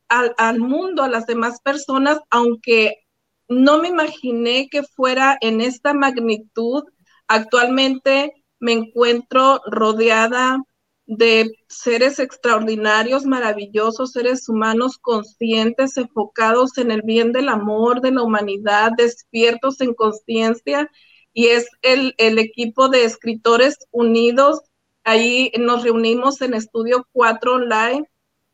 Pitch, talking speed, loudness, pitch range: 235 Hz, 115 wpm, -17 LUFS, 225-260 Hz